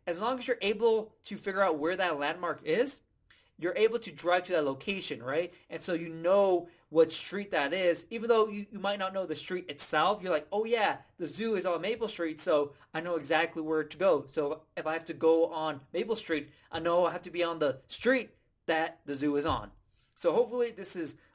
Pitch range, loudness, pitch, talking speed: 160-205 Hz, -31 LUFS, 175 Hz, 230 wpm